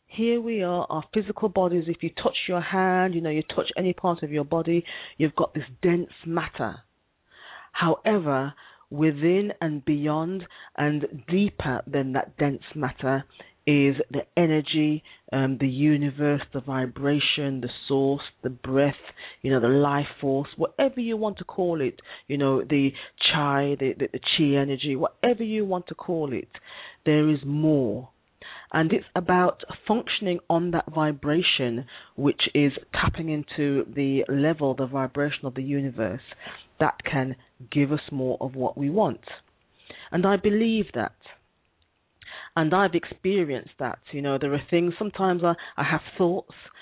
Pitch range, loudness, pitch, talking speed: 140-175 Hz, -25 LUFS, 150 Hz, 155 wpm